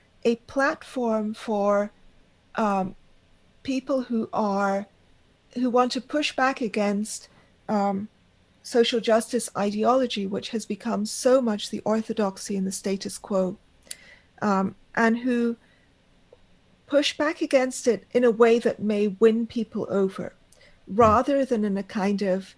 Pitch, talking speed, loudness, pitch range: 220 Hz, 130 wpm, -25 LUFS, 205-245 Hz